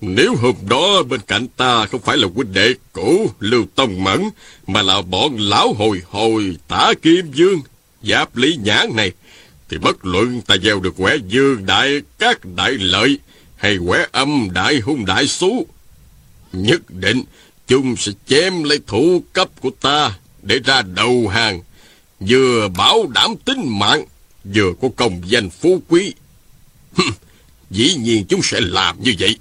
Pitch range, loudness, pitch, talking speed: 95-140 Hz, -15 LUFS, 115 Hz, 160 wpm